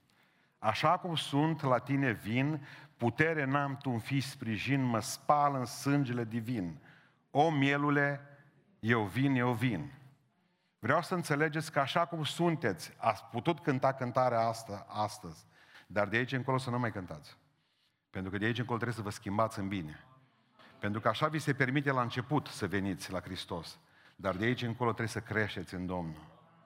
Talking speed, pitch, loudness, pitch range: 170 wpm, 125 Hz, -33 LUFS, 110-145 Hz